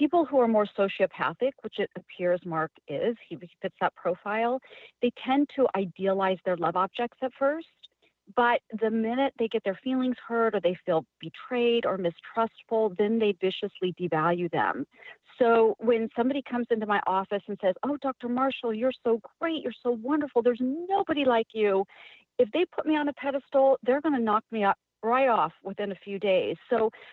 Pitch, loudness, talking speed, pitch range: 230 Hz, -27 LUFS, 190 wpm, 195-260 Hz